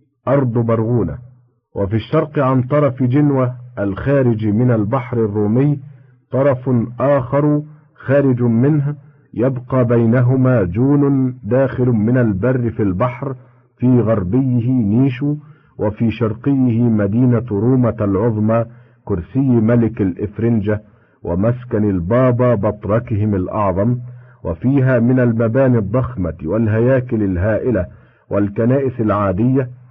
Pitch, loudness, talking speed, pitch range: 120 Hz, -16 LUFS, 90 wpm, 110-130 Hz